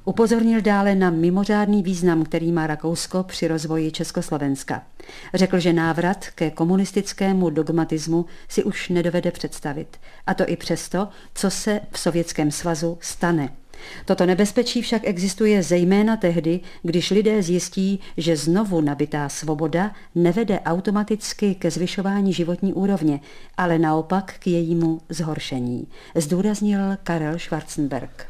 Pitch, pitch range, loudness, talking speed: 175 Hz, 165-195 Hz, -22 LUFS, 125 wpm